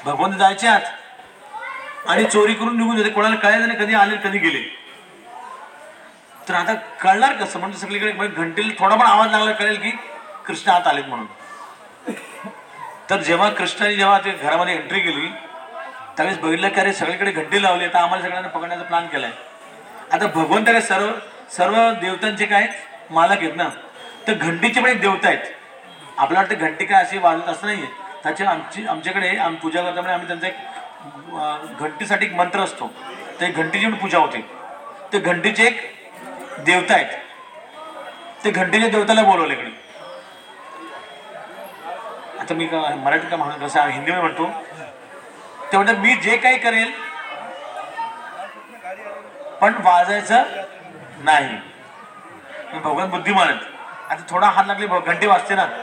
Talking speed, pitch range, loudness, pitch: 140 wpm, 180-225 Hz, -18 LUFS, 200 Hz